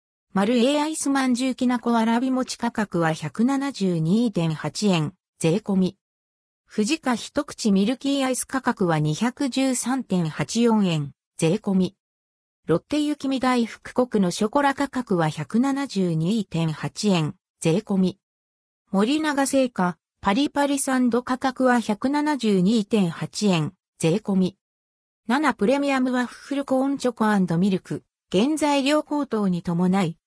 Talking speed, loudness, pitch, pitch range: 210 characters per minute, -23 LUFS, 215 Hz, 175-260 Hz